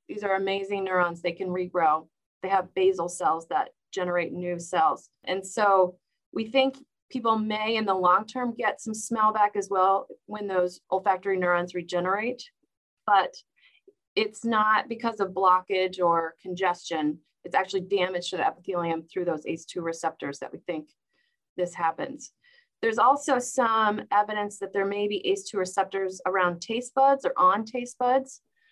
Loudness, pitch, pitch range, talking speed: -26 LUFS, 195 Hz, 180-230 Hz, 160 wpm